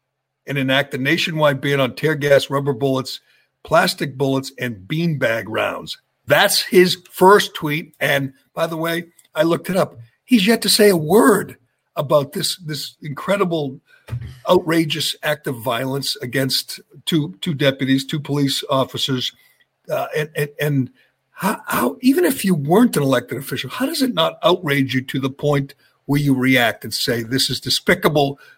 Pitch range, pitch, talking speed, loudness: 135-170 Hz, 145 Hz, 165 wpm, -18 LUFS